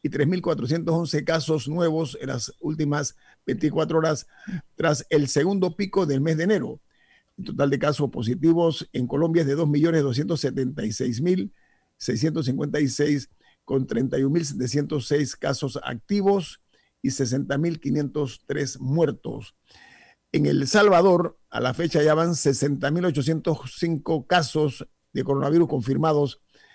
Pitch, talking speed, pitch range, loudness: 150 Hz, 105 wpm, 140-165 Hz, -24 LUFS